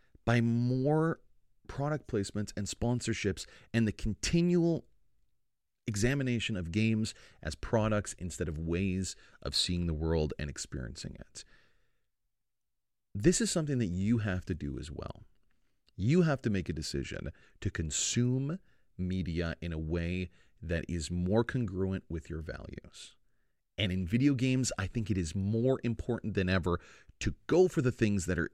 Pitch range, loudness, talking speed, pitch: 85-120 Hz, -33 LUFS, 150 wpm, 100 Hz